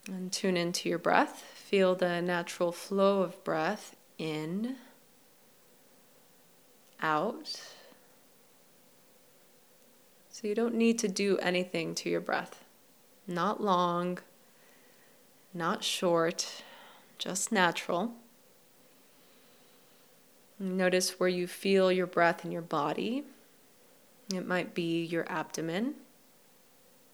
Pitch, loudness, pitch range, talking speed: 185 Hz, -31 LUFS, 175-235 Hz, 95 wpm